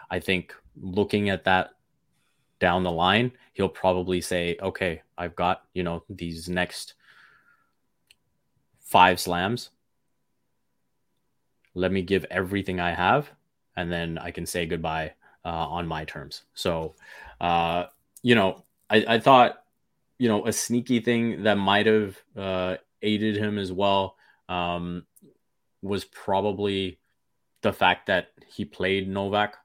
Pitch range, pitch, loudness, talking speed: 90-100 Hz, 95 Hz, -25 LUFS, 130 wpm